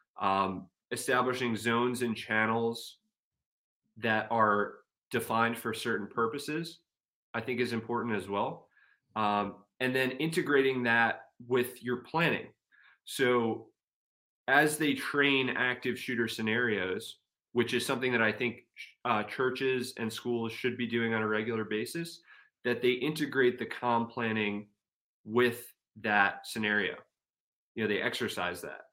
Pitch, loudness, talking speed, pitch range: 120 Hz, -31 LUFS, 130 wpm, 115-130 Hz